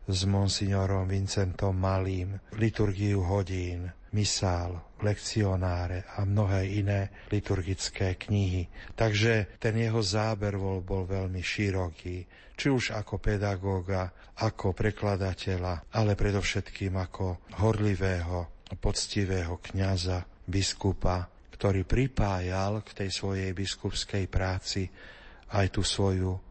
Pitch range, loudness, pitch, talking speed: 95-105 Hz, -30 LUFS, 95 Hz, 95 wpm